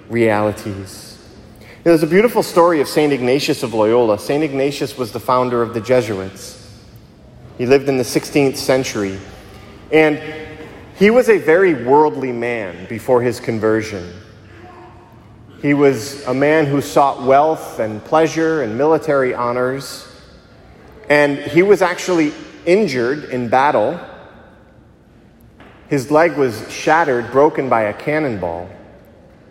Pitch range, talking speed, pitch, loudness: 110-150 Hz, 125 wpm, 130 Hz, -16 LUFS